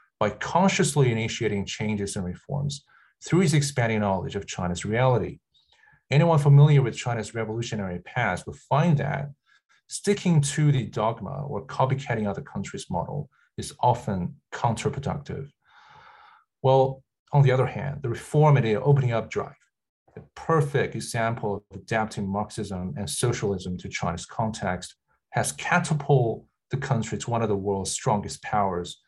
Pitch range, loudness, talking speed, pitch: 105-145 Hz, -25 LUFS, 140 wpm, 120 Hz